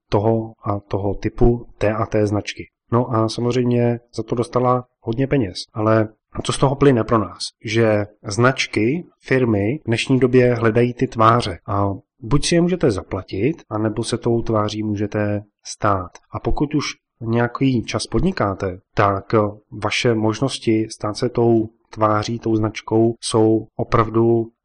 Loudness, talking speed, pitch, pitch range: -20 LUFS, 150 wpm, 115 Hz, 105-120 Hz